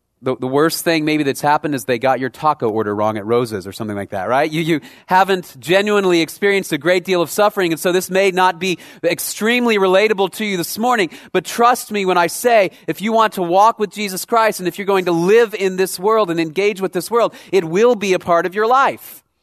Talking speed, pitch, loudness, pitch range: 245 wpm, 185 Hz, -16 LUFS, 160-210 Hz